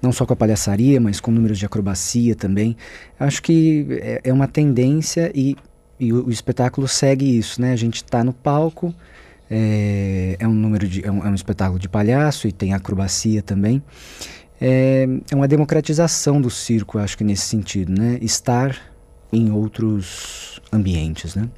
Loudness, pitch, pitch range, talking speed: -19 LUFS, 115 Hz, 100-130 Hz, 165 wpm